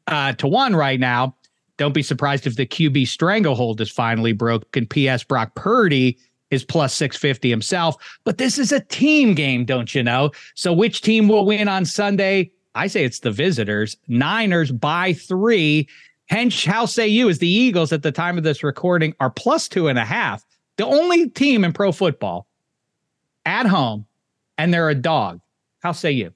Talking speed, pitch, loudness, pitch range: 180 wpm, 155 Hz, -19 LUFS, 130-195 Hz